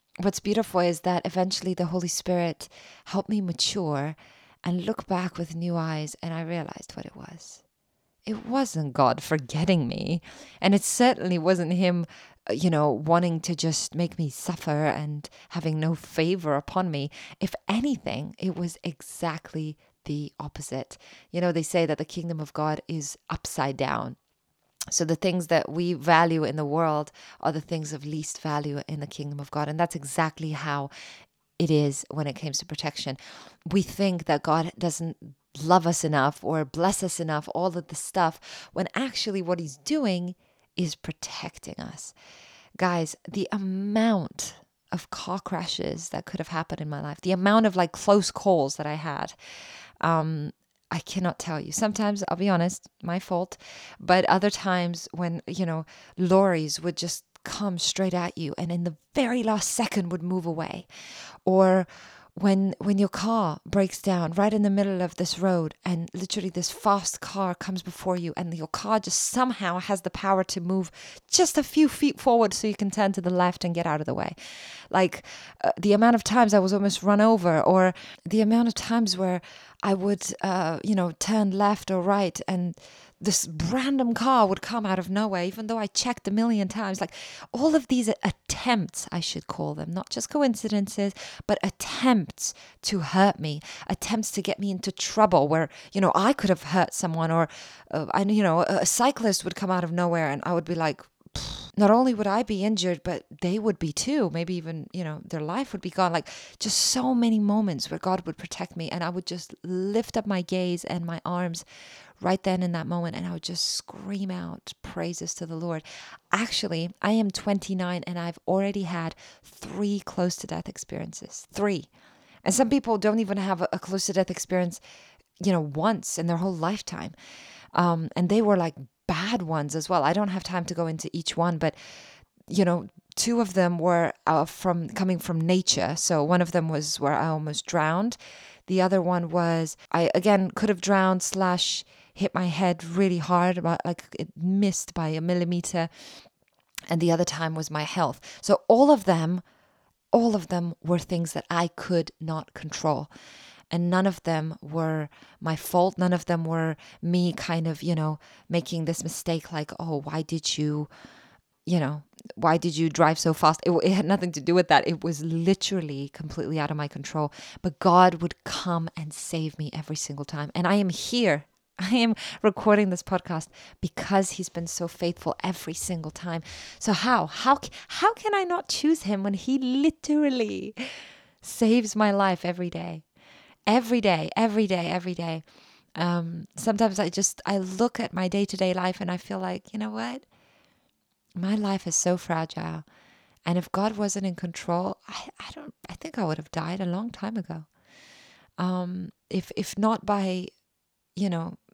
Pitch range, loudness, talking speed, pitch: 165-200 Hz, -26 LUFS, 185 wpm, 180 Hz